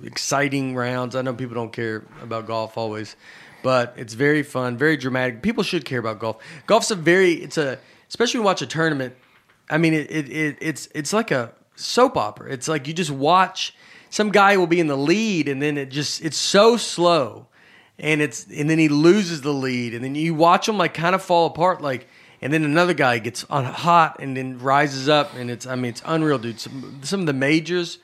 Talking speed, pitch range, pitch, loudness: 225 wpm, 130-170 Hz, 150 Hz, -21 LUFS